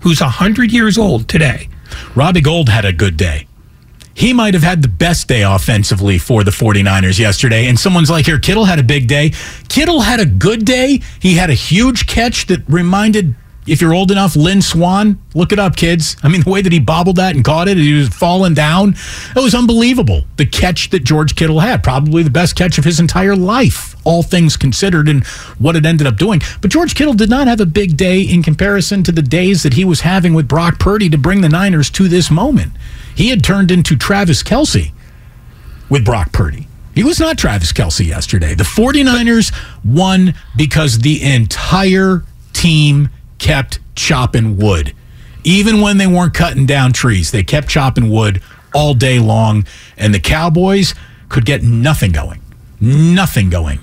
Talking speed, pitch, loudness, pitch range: 190 wpm, 160 Hz, -11 LUFS, 125-190 Hz